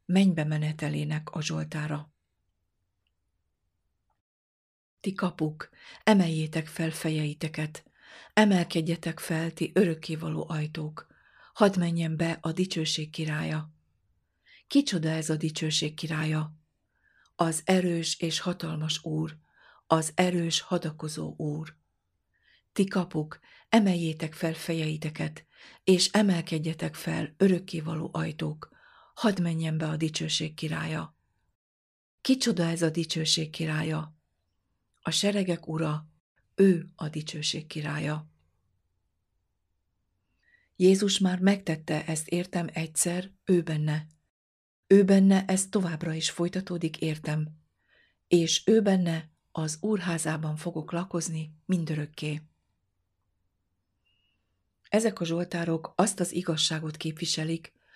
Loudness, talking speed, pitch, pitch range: -28 LUFS, 95 wpm, 160 Hz, 150-175 Hz